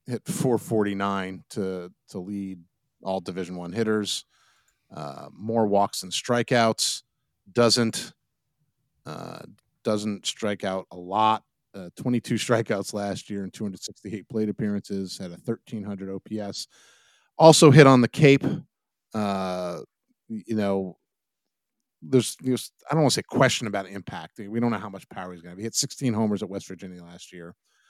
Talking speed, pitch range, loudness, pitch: 155 wpm, 95-120 Hz, -24 LUFS, 105 Hz